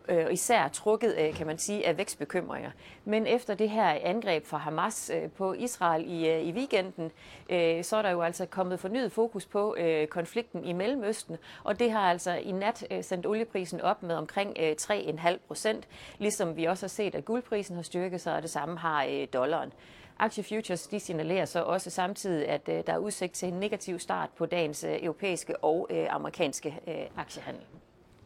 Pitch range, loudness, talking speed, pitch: 165-210 Hz, -31 LUFS, 170 wpm, 180 Hz